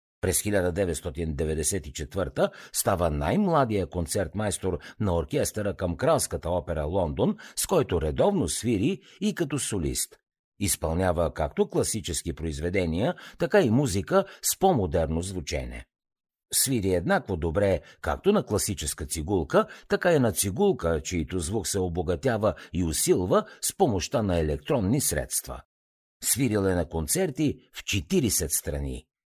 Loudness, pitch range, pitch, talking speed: -26 LUFS, 80-105 Hz, 90 Hz, 115 wpm